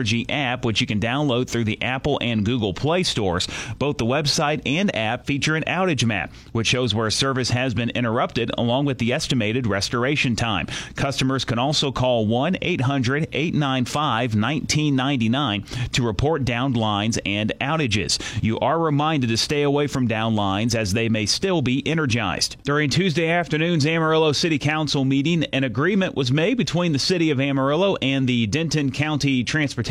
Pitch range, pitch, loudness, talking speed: 115-150 Hz, 135 Hz, -21 LUFS, 175 wpm